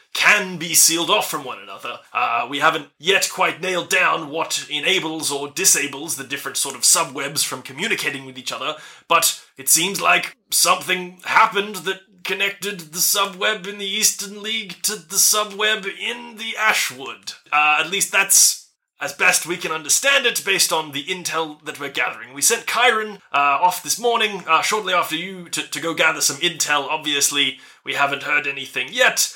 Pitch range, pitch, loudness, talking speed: 150-205 Hz, 180 Hz, -18 LUFS, 180 wpm